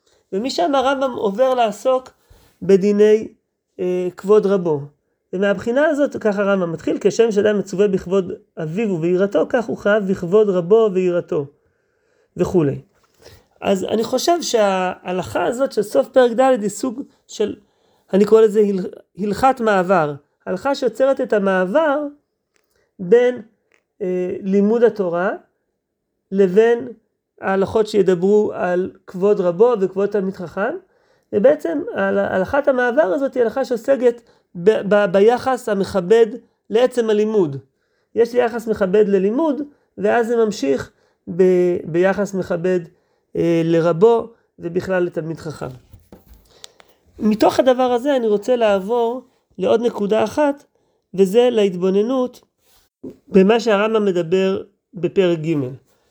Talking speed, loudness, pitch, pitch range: 110 wpm, -18 LUFS, 210 Hz, 190-245 Hz